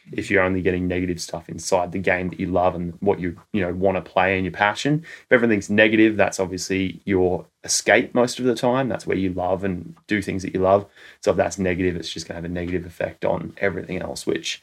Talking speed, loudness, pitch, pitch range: 245 wpm, -22 LUFS, 95 Hz, 90-100 Hz